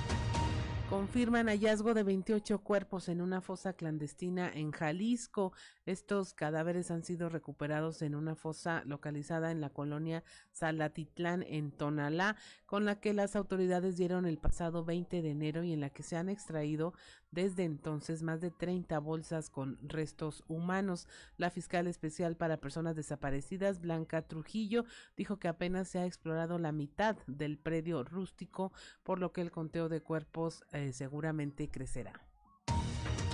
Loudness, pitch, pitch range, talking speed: -38 LUFS, 165 Hz, 150-185 Hz, 150 wpm